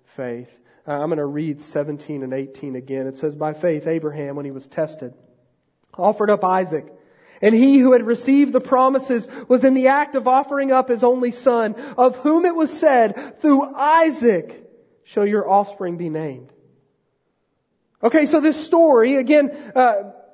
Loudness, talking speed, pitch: -18 LUFS, 165 wpm, 230 Hz